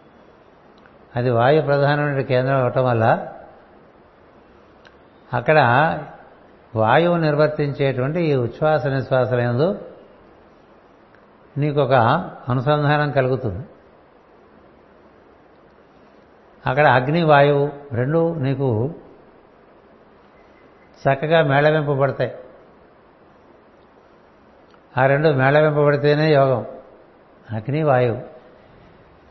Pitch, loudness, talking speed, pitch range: 140 Hz, -18 LUFS, 60 wpm, 130-150 Hz